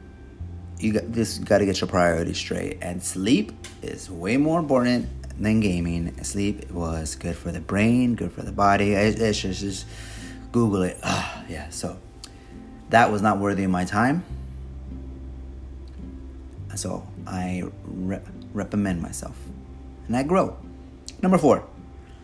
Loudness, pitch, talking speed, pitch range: -24 LUFS, 90 Hz, 135 wpm, 65-100 Hz